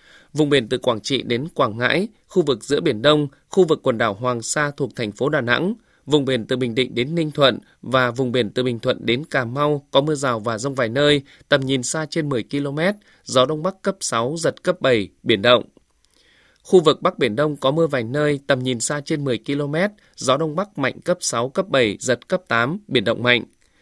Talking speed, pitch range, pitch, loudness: 235 wpm, 125-155 Hz, 140 Hz, -20 LUFS